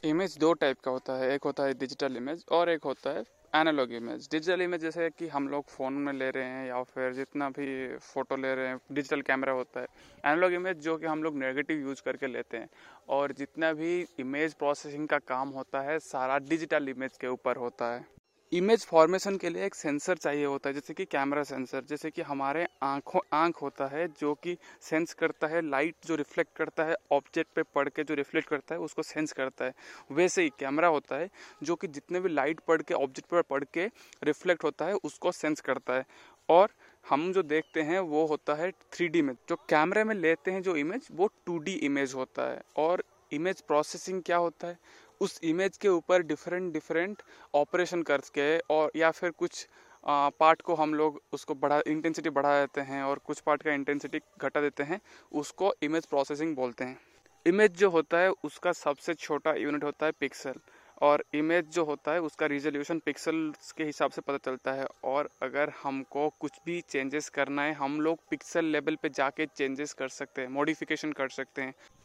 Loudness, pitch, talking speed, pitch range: -31 LUFS, 150 Hz, 200 wpm, 140-165 Hz